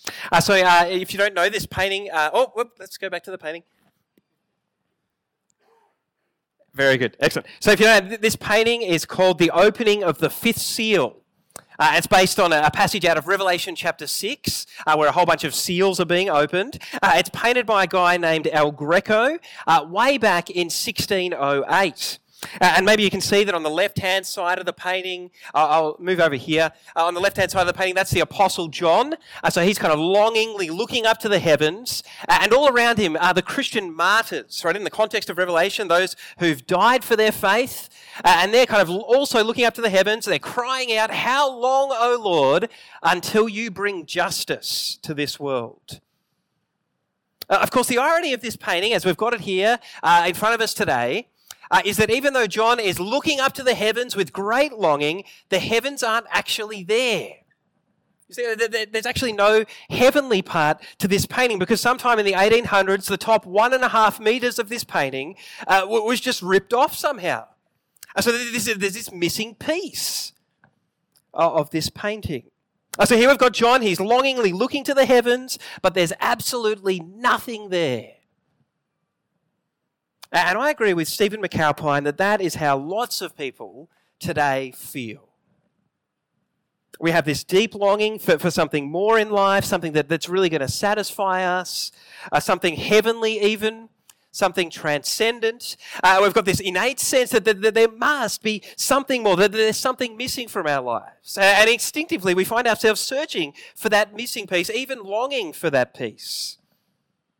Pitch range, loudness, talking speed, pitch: 175-230 Hz, -20 LUFS, 185 wpm, 200 Hz